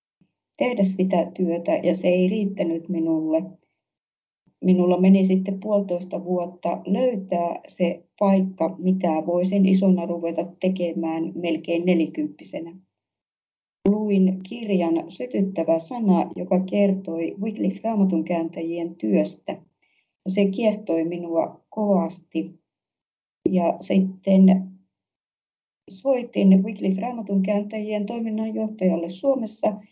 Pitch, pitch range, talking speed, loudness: 185 Hz, 170-200 Hz, 90 wpm, -23 LUFS